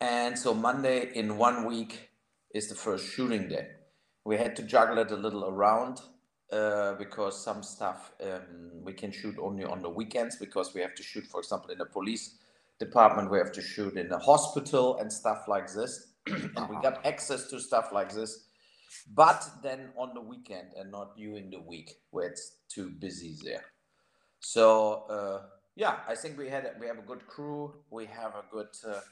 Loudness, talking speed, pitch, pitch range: -30 LUFS, 190 wpm, 110 Hz, 100-120 Hz